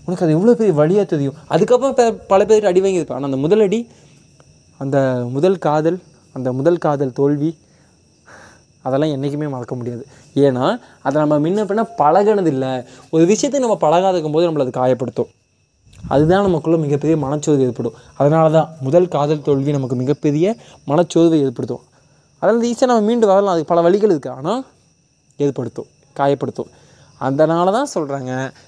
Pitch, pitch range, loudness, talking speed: 150 Hz, 135-180 Hz, -16 LUFS, 150 wpm